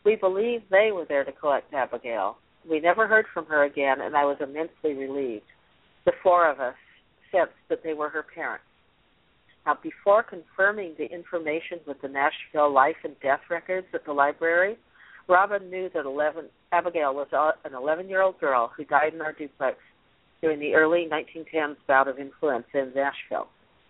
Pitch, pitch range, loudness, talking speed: 155 Hz, 145-180 Hz, -25 LUFS, 165 wpm